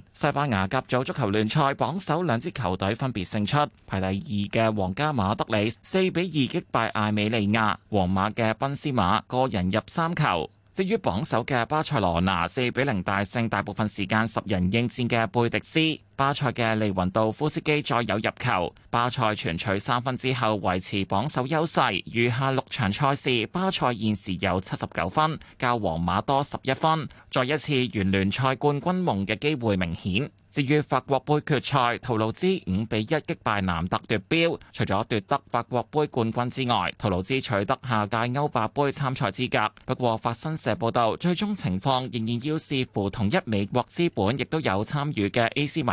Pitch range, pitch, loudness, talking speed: 105-140 Hz, 120 Hz, -25 LUFS, 280 characters per minute